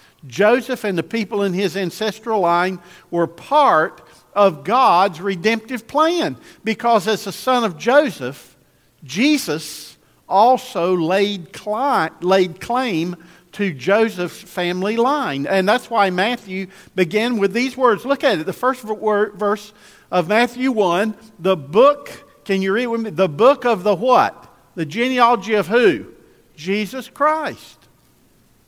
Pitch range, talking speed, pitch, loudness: 185-240 Hz, 130 wpm, 210 Hz, -18 LUFS